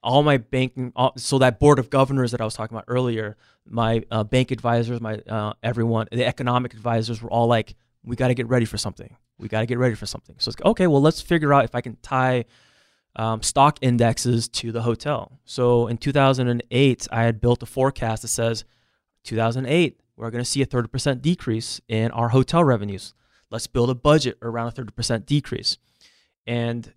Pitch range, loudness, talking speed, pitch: 115-130 Hz, -22 LUFS, 200 wpm, 120 Hz